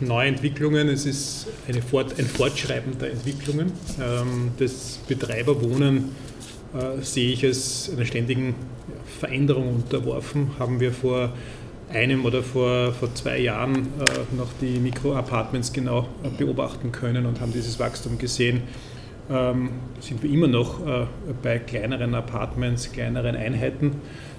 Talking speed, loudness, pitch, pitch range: 115 wpm, -25 LUFS, 125 Hz, 120-135 Hz